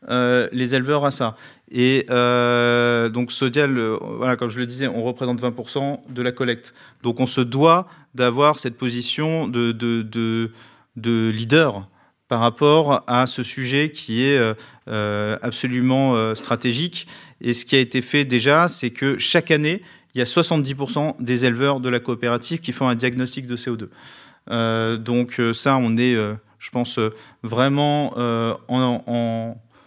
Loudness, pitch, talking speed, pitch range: -20 LUFS, 125 Hz, 165 wpm, 120-135 Hz